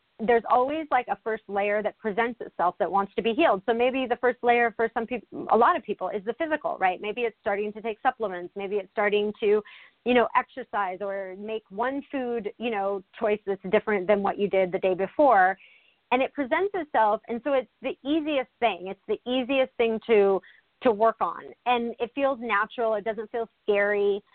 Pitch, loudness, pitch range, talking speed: 225 Hz, -26 LUFS, 205-245 Hz, 210 wpm